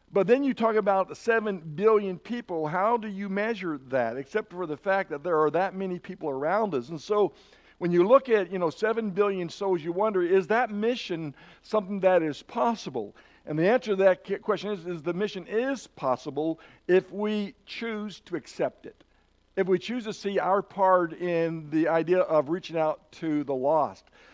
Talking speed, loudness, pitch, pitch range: 195 wpm, -27 LUFS, 190 Hz, 170-210 Hz